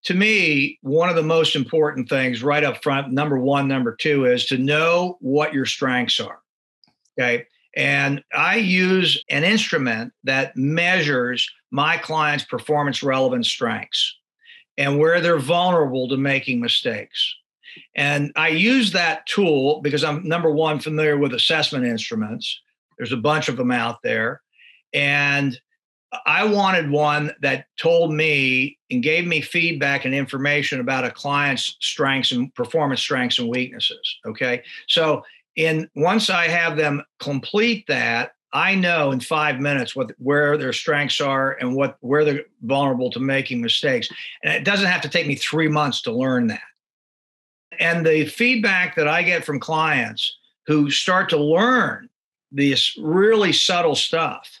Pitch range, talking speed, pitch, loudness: 135-170 Hz, 155 wpm, 150 Hz, -19 LUFS